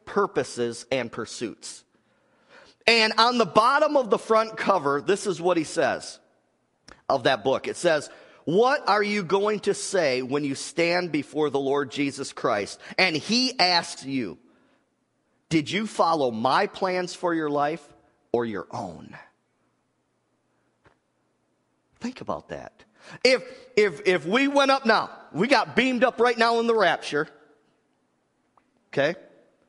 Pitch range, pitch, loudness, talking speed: 145-220 Hz, 180 Hz, -24 LUFS, 140 wpm